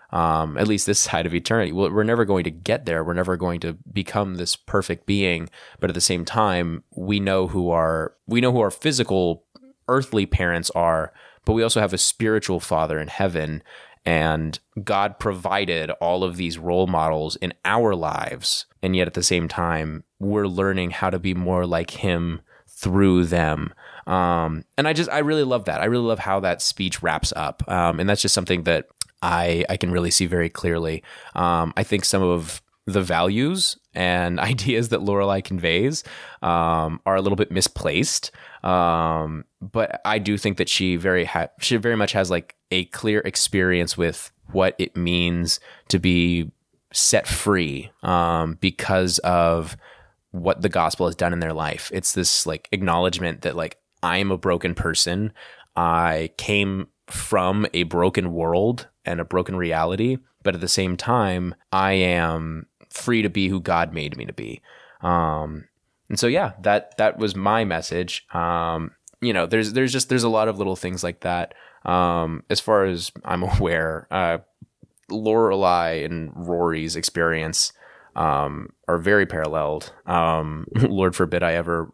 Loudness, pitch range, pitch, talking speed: -22 LUFS, 85-100 Hz, 90 Hz, 175 wpm